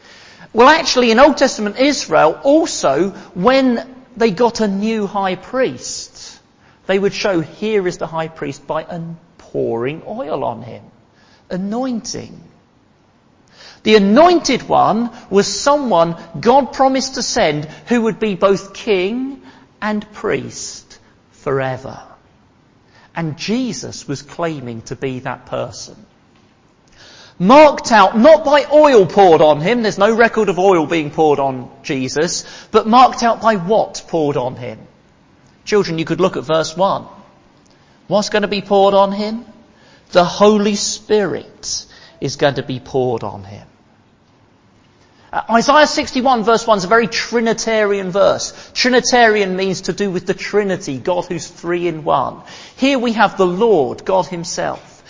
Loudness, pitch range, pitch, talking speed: -15 LUFS, 165-235 Hz, 200 Hz, 140 wpm